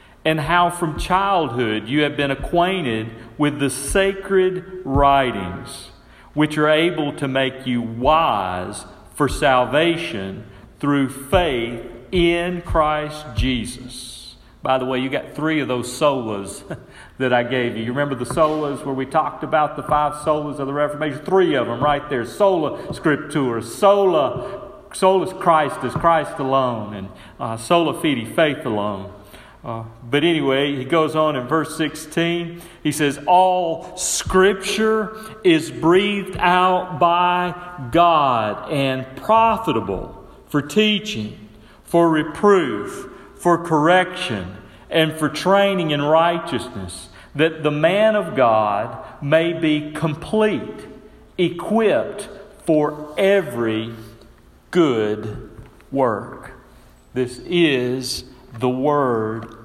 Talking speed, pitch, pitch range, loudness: 120 wpm, 150 Hz, 125-170 Hz, -19 LUFS